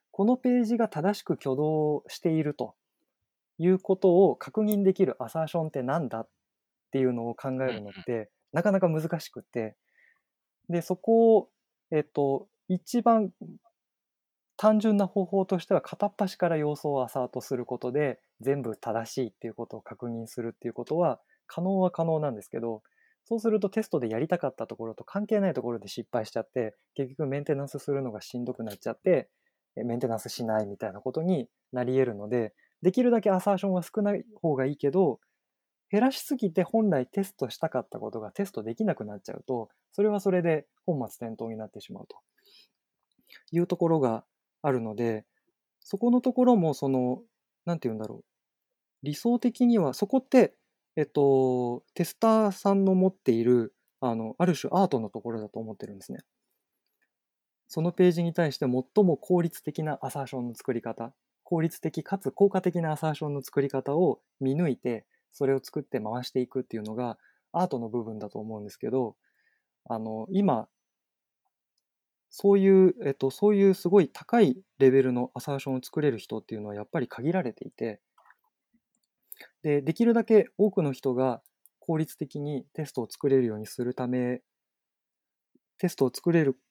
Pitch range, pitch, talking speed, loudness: 125-195 Hz, 150 Hz, 355 characters per minute, -28 LUFS